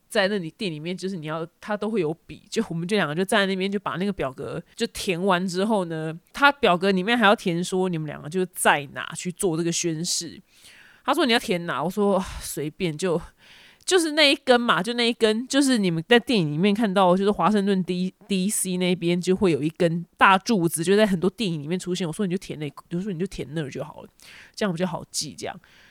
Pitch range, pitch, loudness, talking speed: 170-210 Hz, 185 Hz, -23 LUFS, 335 characters per minute